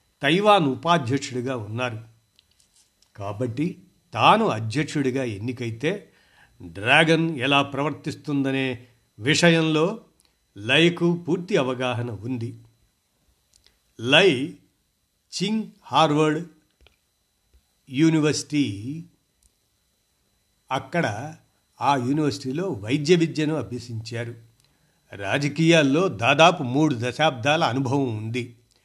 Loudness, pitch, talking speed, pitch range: -22 LUFS, 140 Hz, 65 wpm, 120-160 Hz